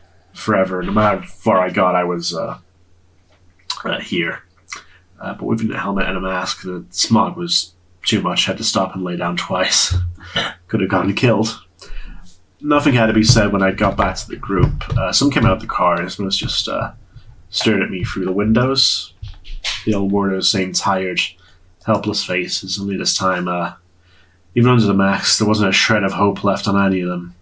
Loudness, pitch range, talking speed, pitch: -17 LUFS, 90-105 Hz, 200 wpm, 95 Hz